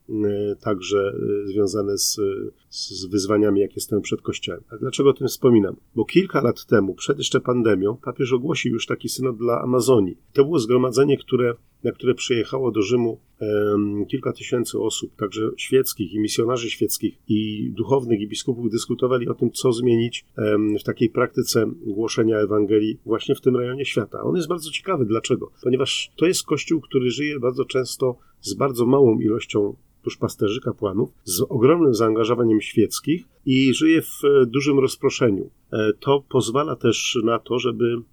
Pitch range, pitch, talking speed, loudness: 110-135 Hz, 120 Hz, 155 wpm, -21 LUFS